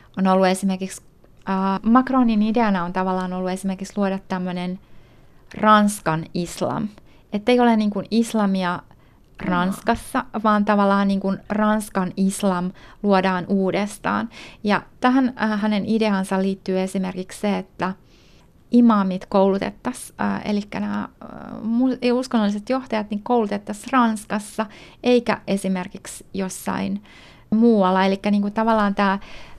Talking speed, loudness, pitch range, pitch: 115 wpm, -21 LUFS, 190-220 Hz, 200 Hz